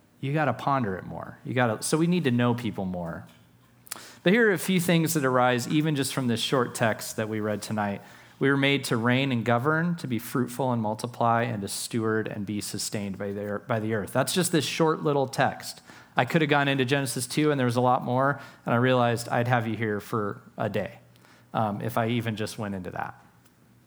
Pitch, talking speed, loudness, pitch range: 120 Hz, 230 wpm, -26 LUFS, 105-140 Hz